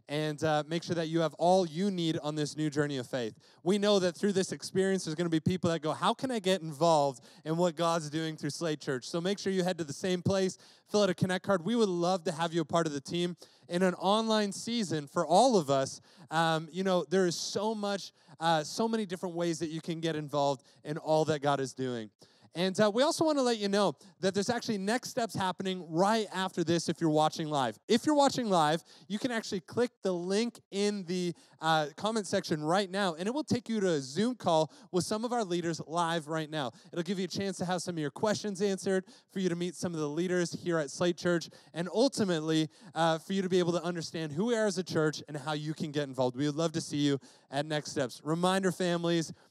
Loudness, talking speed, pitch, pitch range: -31 LUFS, 250 wpm, 175 Hz, 160-195 Hz